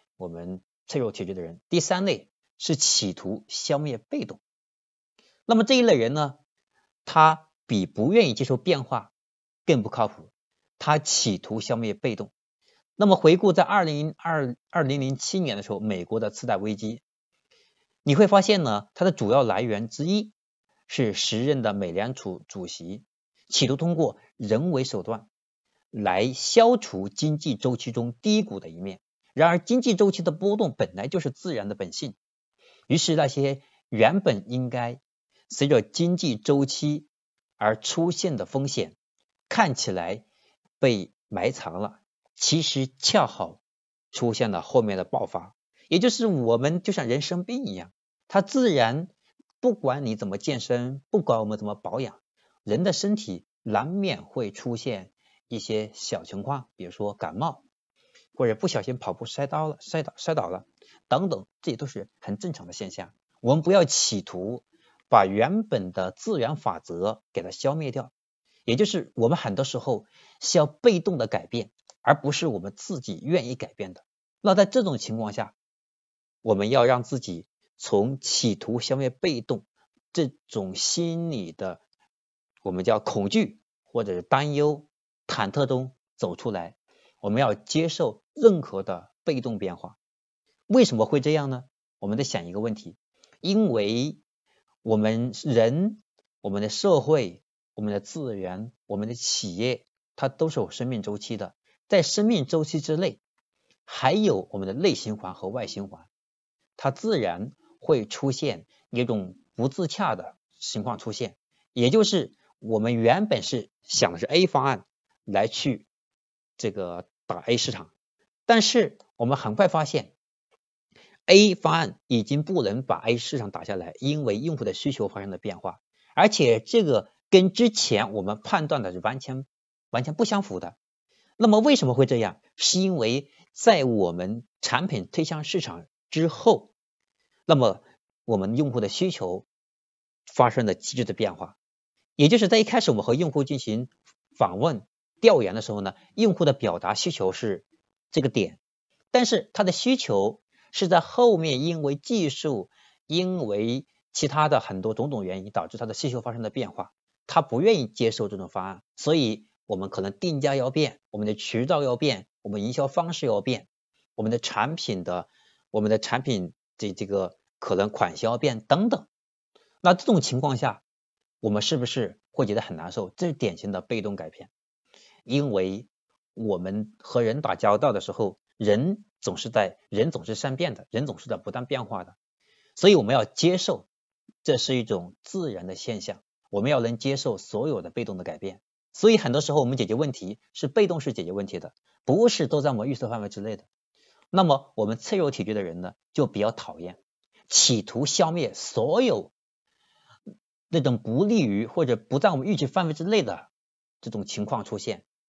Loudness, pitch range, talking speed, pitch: -25 LUFS, 110-175 Hz, 245 characters per minute, 135 Hz